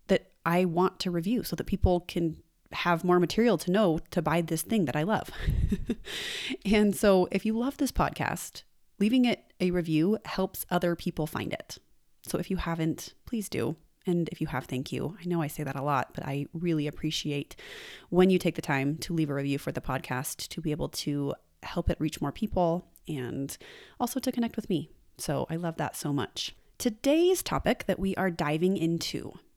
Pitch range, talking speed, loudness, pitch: 155-195 Hz, 200 wpm, -29 LUFS, 170 Hz